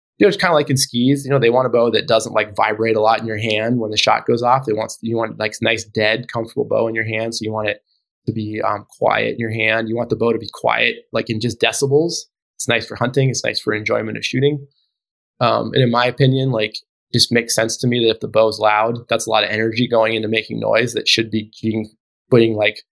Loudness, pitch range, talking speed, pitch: -17 LUFS, 110-120 Hz, 265 wpm, 115 Hz